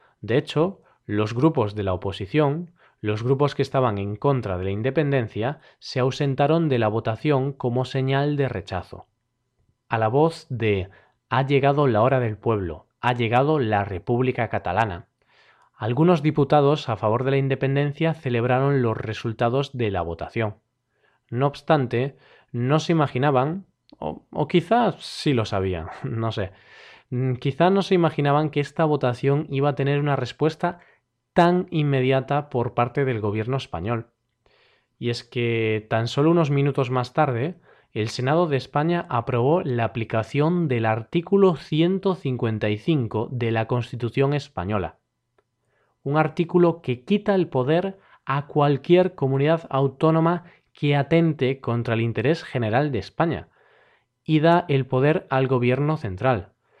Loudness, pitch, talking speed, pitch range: -23 LUFS, 135 Hz, 140 wpm, 115-150 Hz